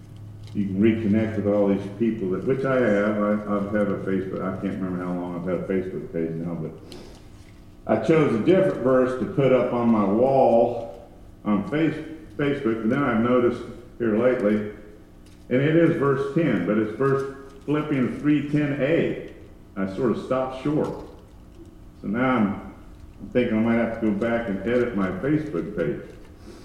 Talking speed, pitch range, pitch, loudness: 180 wpm, 100-130 Hz, 115 Hz, -23 LUFS